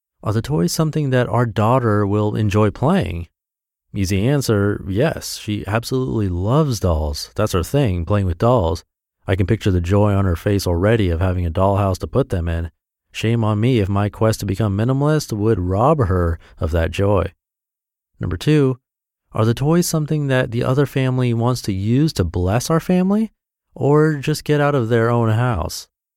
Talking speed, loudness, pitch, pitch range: 185 wpm, -18 LUFS, 110 Hz, 95-130 Hz